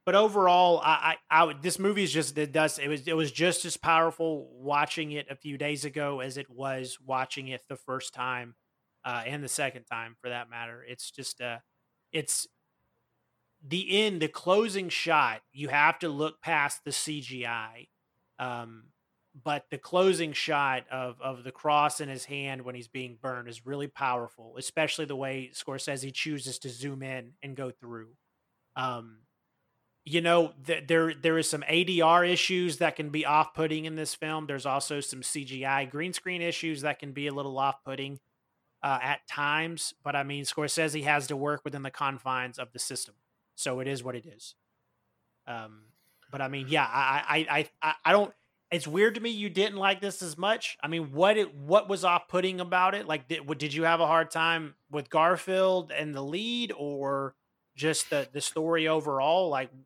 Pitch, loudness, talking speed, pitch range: 145 Hz, -29 LUFS, 190 wpm, 130-165 Hz